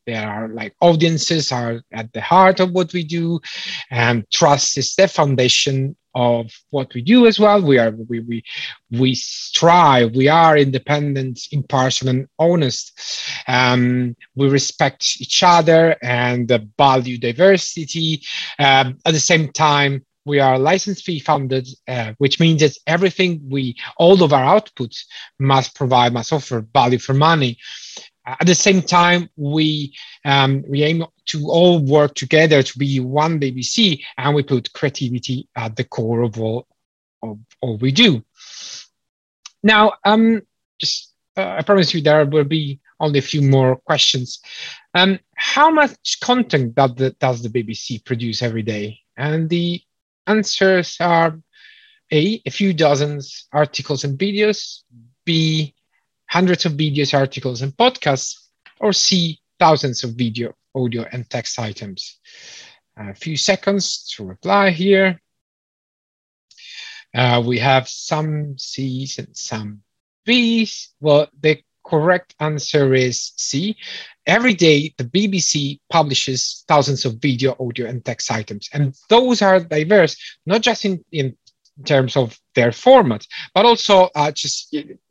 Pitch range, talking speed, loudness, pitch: 125-170 Hz, 140 wpm, -16 LUFS, 145 Hz